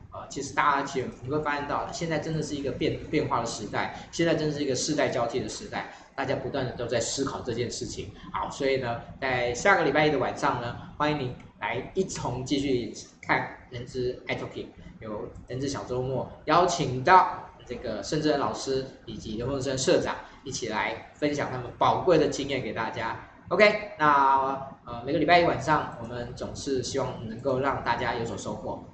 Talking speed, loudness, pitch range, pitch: 305 characters per minute, -27 LUFS, 120-150 Hz, 135 Hz